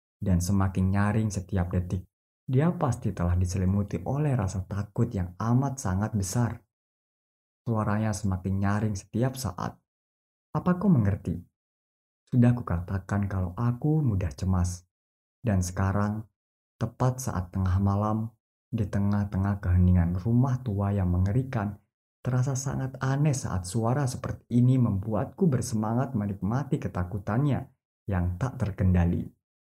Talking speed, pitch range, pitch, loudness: 115 wpm, 95-120 Hz, 105 Hz, -28 LUFS